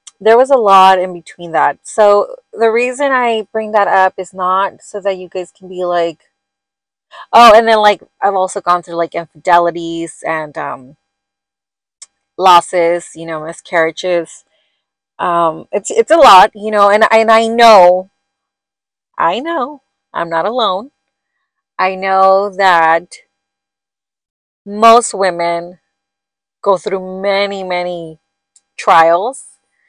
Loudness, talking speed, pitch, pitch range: -12 LUFS, 130 wpm, 185 Hz, 165-205 Hz